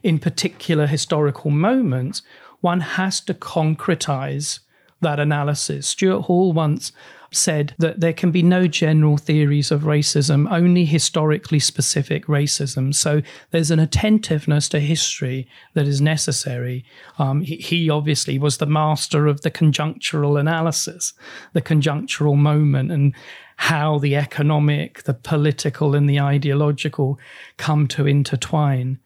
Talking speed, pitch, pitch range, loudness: 130 wpm, 150 Hz, 145-160 Hz, -19 LUFS